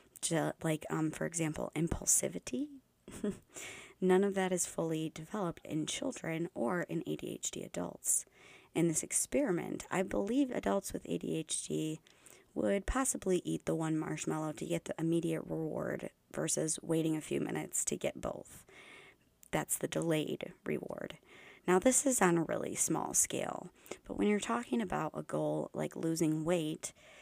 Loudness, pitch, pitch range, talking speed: -35 LUFS, 165 Hz, 155-185 Hz, 145 wpm